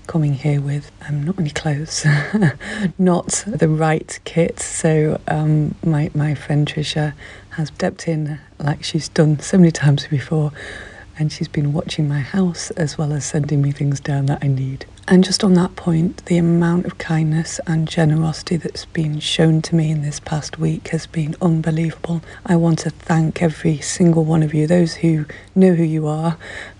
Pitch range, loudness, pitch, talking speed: 150-170 Hz, -18 LUFS, 160 Hz, 180 wpm